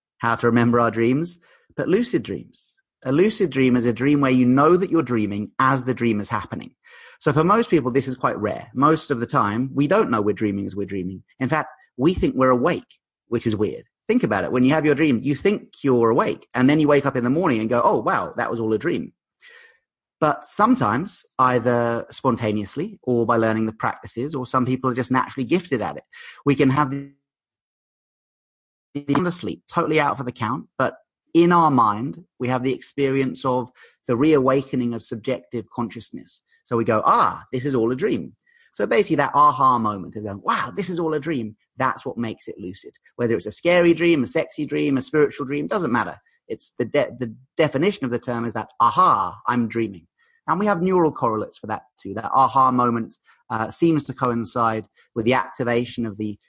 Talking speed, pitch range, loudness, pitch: 210 wpm, 115-150 Hz, -21 LUFS, 130 Hz